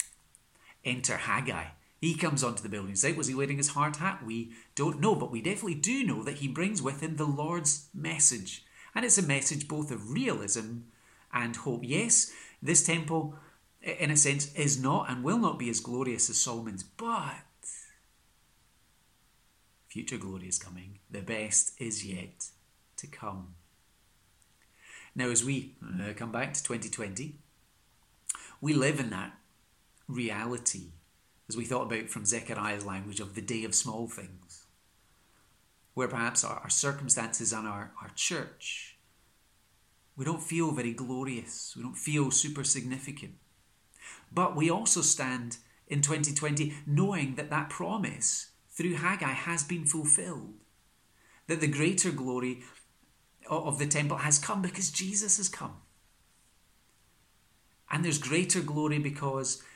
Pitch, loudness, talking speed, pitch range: 135 Hz, -30 LUFS, 145 wpm, 115-155 Hz